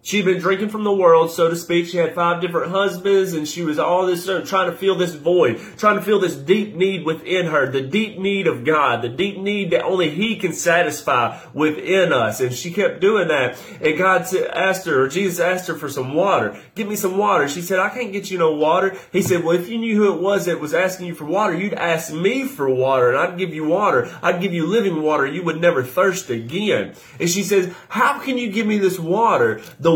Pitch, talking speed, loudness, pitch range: 185 Hz, 240 wpm, -19 LUFS, 165-195 Hz